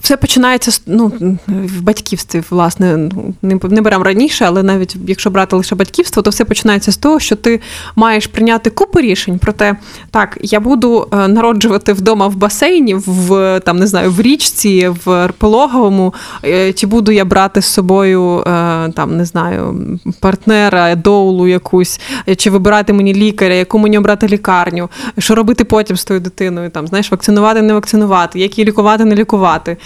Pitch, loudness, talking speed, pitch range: 200 Hz, -11 LUFS, 160 wpm, 185-220 Hz